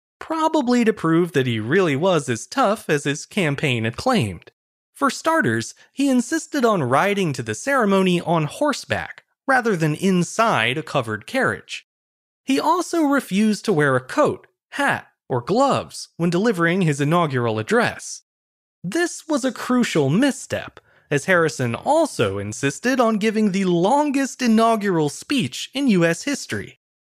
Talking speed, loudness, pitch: 140 wpm, -20 LUFS, 195 Hz